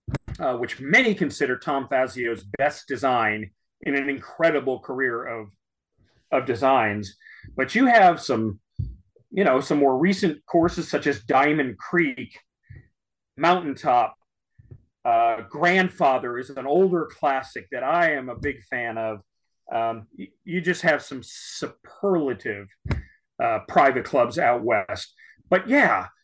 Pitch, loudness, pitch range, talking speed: 140 Hz, -23 LUFS, 115-175 Hz, 130 wpm